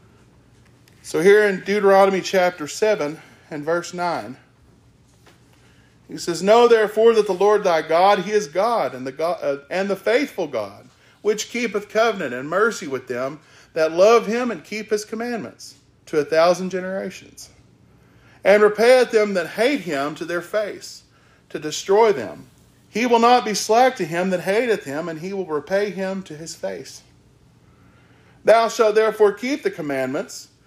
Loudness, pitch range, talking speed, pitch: -19 LUFS, 160-215 Hz, 160 wpm, 195 Hz